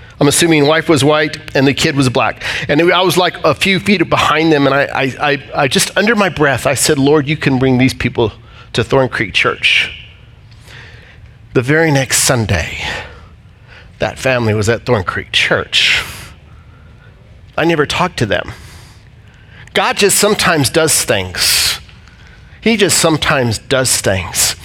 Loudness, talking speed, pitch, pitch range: -12 LUFS, 160 wpm, 130 Hz, 110-155 Hz